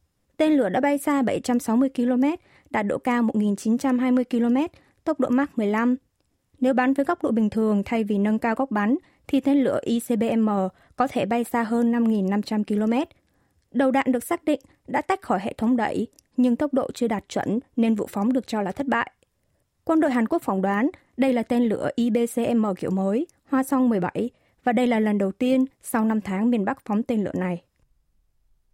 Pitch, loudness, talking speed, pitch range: 240 Hz, -24 LUFS, 200 wpm, 215-265 Hz